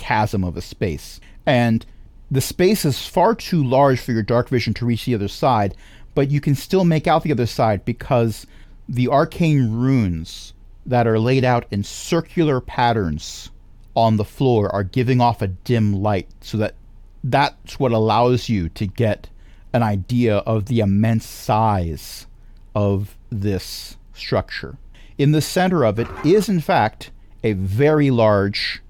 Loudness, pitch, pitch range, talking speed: -19 LUFS, 115 Hz, 100-130 Hz, 160 wpm